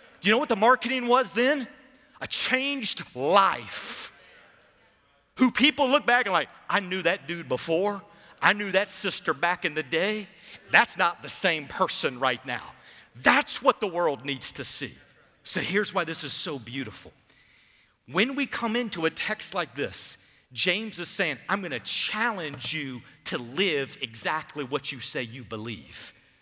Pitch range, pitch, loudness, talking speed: 140-220 Hz, 175 Hz, -26 LUFS, 165 wpm